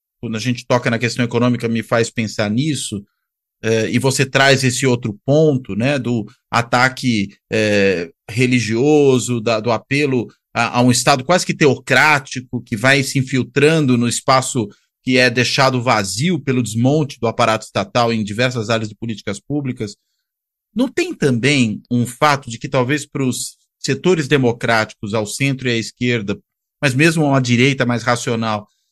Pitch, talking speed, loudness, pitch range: 125 Hz, 160 wpm, -17 LUFS, 115-135 Hz